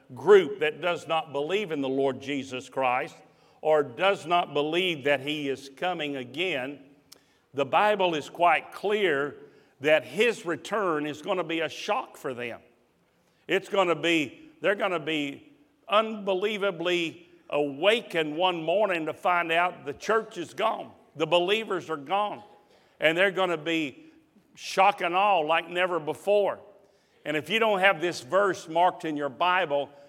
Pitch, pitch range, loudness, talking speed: 175 Hz, 150-200 Hz, -26 LUFS, 160 wpm